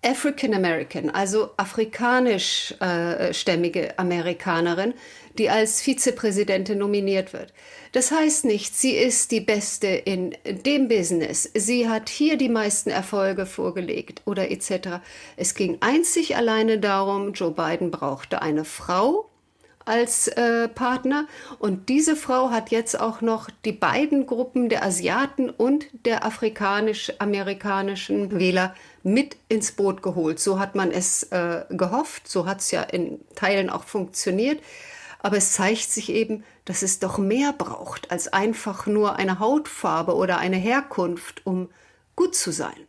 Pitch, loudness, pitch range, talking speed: 210 Hz, -23 LUFS, 190-245 Hz, 140 wpm